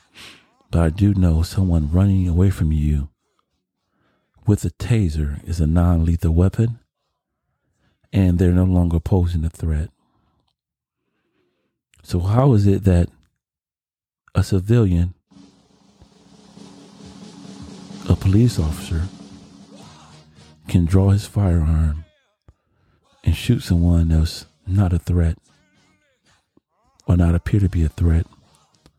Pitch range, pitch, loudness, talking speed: 80-95 Hz, 90 Hz, -19 LUFS, 110 wpm